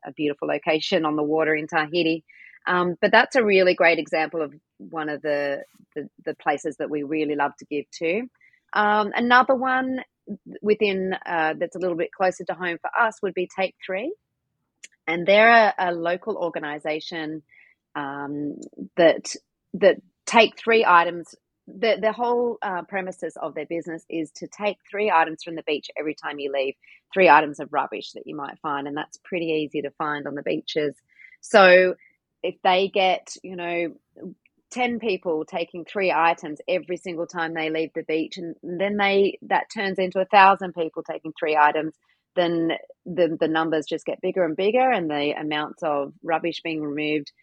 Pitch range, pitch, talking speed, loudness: 155-195 Hz, 170 Hz, 180 wpm, -23 LUFS